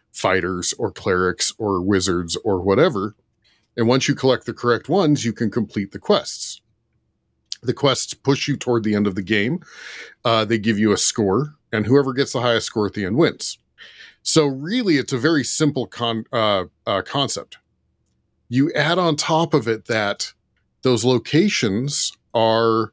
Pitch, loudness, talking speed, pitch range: 120 Hz, -20 LUFS, 170 wpm, 110-140 Hz